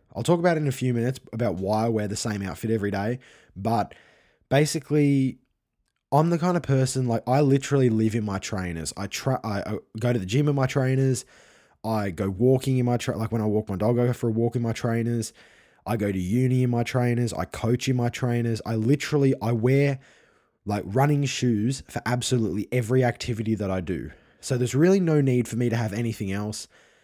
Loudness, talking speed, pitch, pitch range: -25 LUFS, 220 wpm, 120 Hz, 110-130 Hz